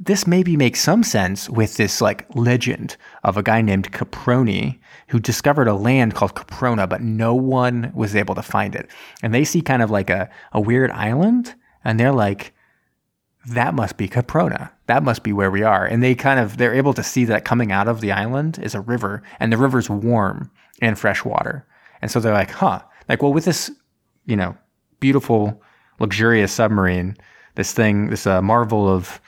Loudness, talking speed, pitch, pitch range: -19 LUFS, 195 wpm, 115 Hz, 105-125 Hz